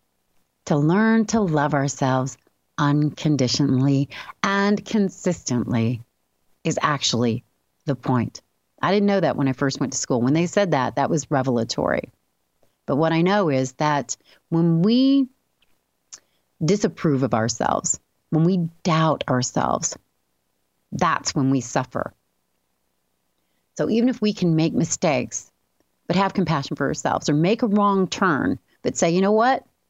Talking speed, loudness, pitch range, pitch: 140 wpm, -22 LUFS, 130-190 Hz, 150 Hz